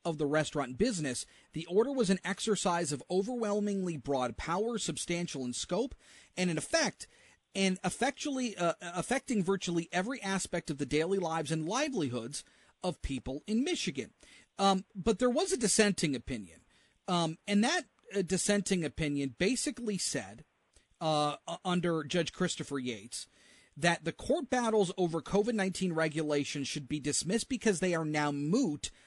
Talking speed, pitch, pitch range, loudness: 150 wpm, 180 Hz, 155-210 Hz, -33 LUFS